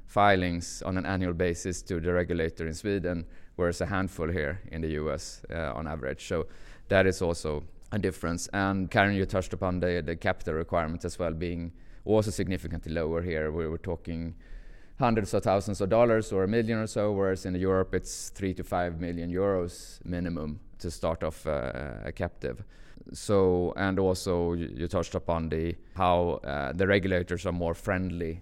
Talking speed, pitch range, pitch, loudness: 175 wpm, 85-95 Hz, 90 Hz, -30 LUFS